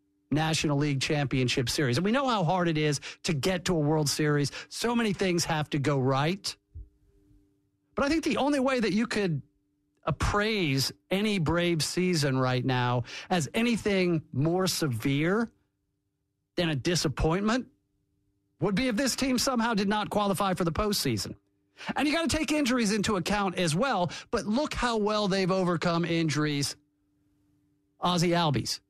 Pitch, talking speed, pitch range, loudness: 165 Hz, 160 wpm, 140-205 Hz, -28 LUFS